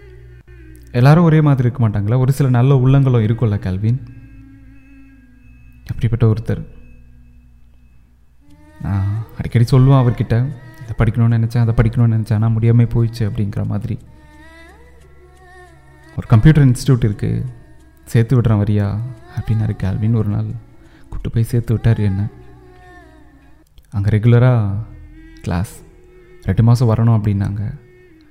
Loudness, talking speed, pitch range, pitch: -16 LUFS, 110 wpm, 80-120 Hz, 110 Hz